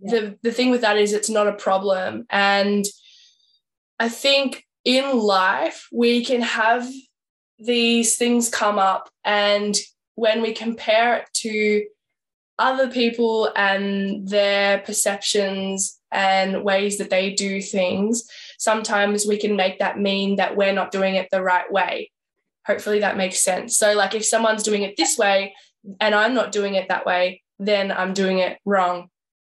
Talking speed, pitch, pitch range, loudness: 155 wpm, 205 Hz, 195-230 Hz, -20 LUFS